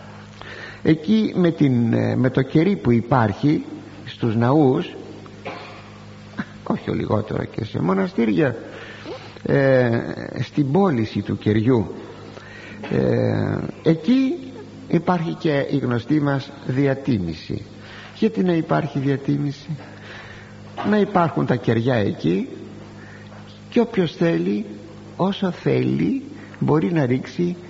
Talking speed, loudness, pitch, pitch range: 100 wpm, -21 LUFS, 130 Hz, 105-165 Hz